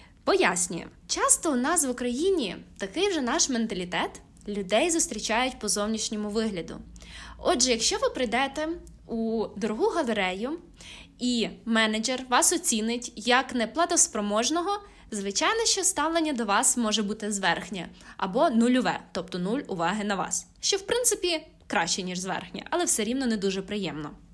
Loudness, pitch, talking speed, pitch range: -26 LUFS, 230 Hz, 135 wpm, 205-315 Hz